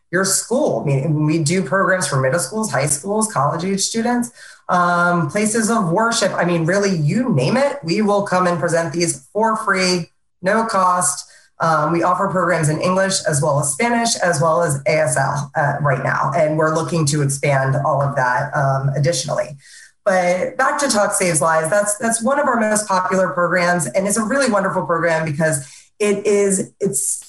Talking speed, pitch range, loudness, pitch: 190 wpm, 160-205 Hz, -17 LUFS, 180 Hz